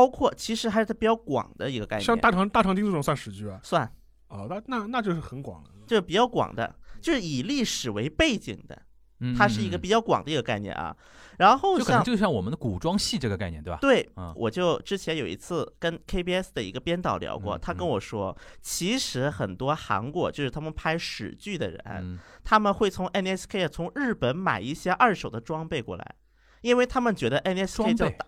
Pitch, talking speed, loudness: 175 Hz, 320 characters per minute, -26 LUFS